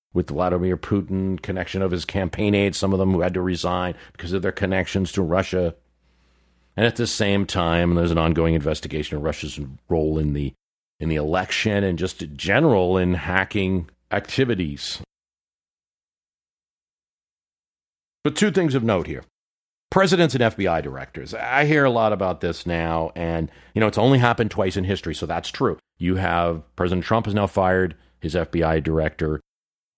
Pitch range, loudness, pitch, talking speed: 80-100 Hz, -22 LUFS, 90 Hz, 170 wpm